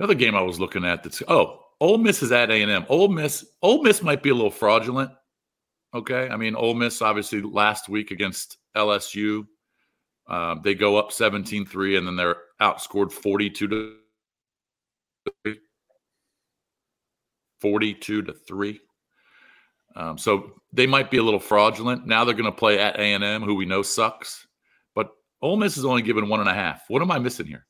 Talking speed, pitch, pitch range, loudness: 170 wpm, 105 Hz, 105-125 Hz, -22 LUFS